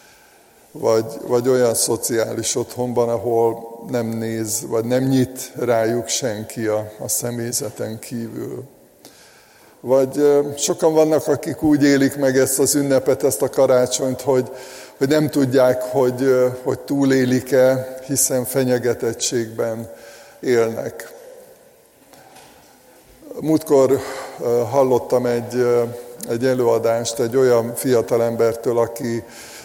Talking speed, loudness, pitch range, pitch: 100 wpm, -19 LUFS, 115-135 Hz, 125 Hz